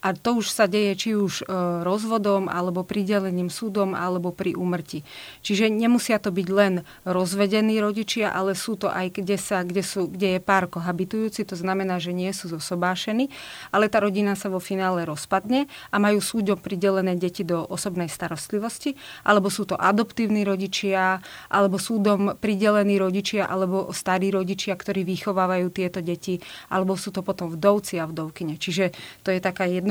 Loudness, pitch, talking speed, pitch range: -24 LUFS, 195 Hz, 165 wpm, 185-205 Hz